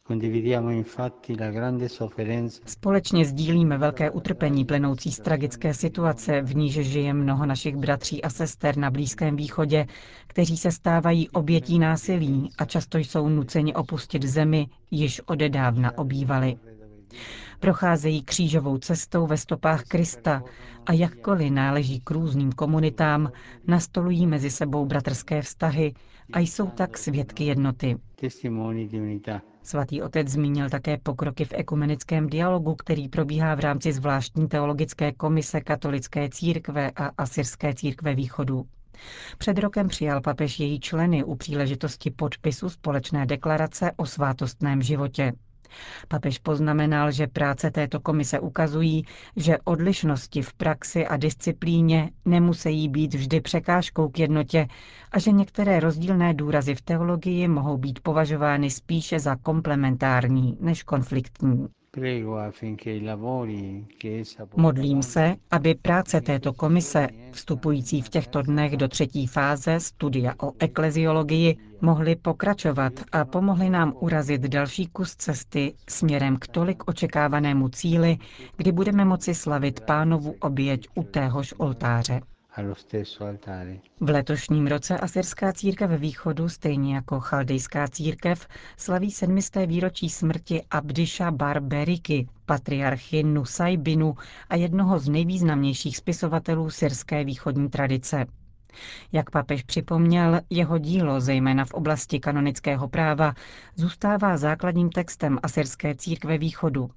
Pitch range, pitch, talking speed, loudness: 135-165 Hz, 150 Hz, 115 wpm, -25 LUFS